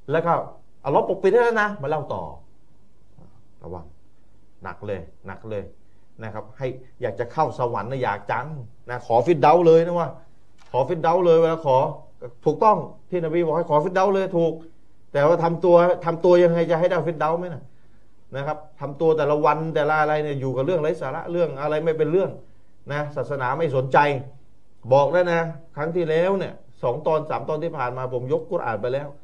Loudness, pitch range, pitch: -22 LUFS, 125-170 Hz, 150 Hz